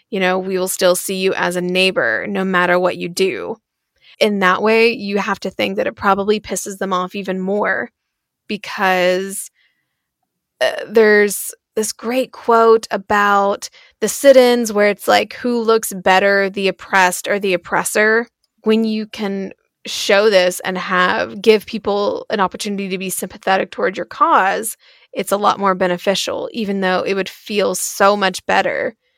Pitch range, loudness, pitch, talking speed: 185-220 Hz, -16 LUFS, 200 Hz, 165 wpm